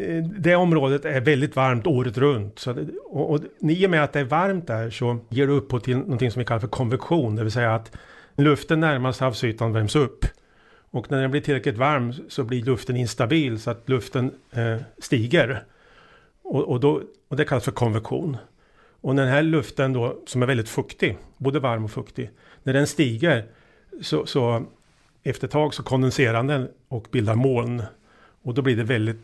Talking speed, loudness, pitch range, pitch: 195 wpm, -23 LUFS, 120-145 Hz, 130 Hz